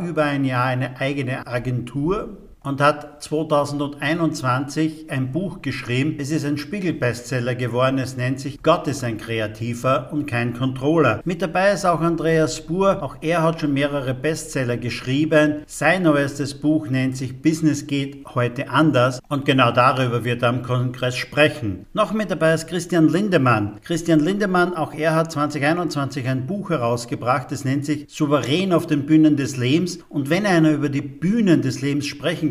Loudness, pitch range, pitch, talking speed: -21 LUFS, 130-160 Hz, 145 Hz, 165 wpm